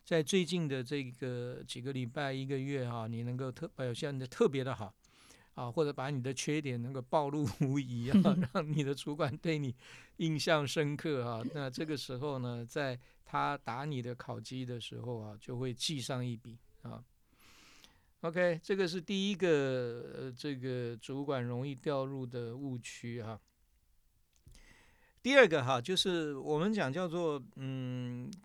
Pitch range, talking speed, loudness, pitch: 125-155 Hz, 235 characters per minute, -35 LUFS, 135 Hz